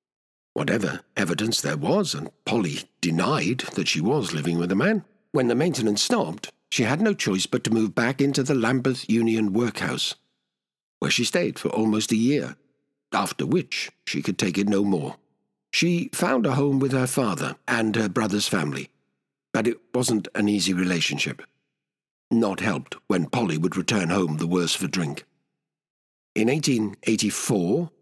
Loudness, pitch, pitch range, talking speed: -24 LUFS, 110 Hz, 95-130 Hz, 165 wpm